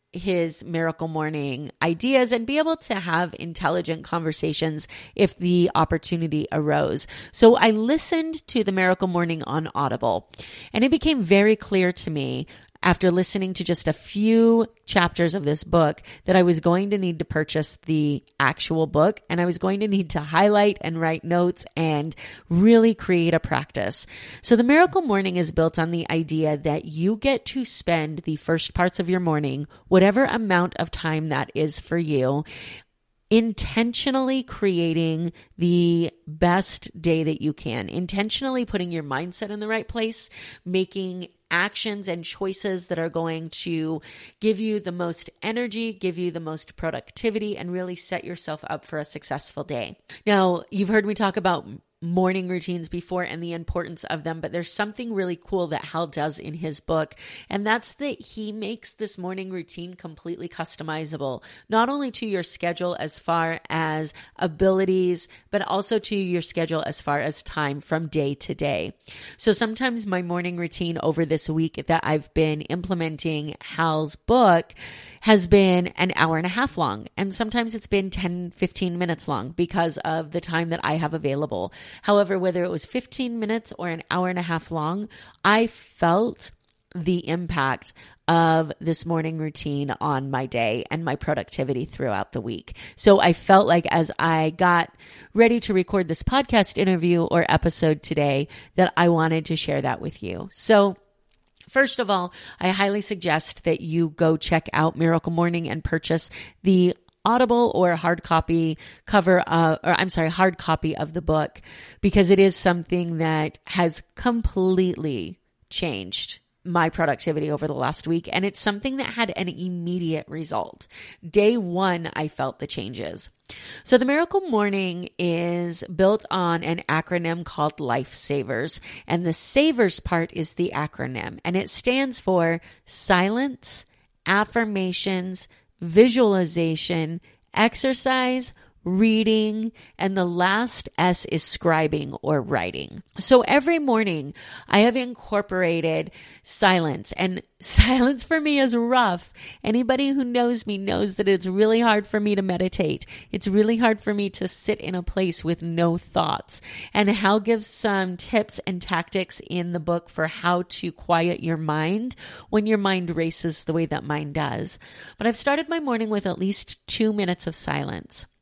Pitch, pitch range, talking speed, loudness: 175 Hz, 160-205 Hz, 165 wpm, -23 LUFS